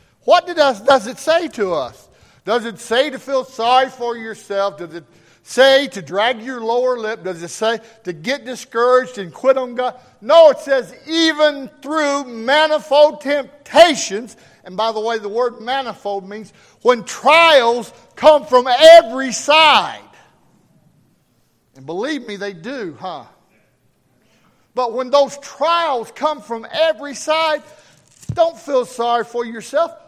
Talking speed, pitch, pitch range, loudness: 145 wpm, 255 Hz, 225-295 Hz, -15 LUFS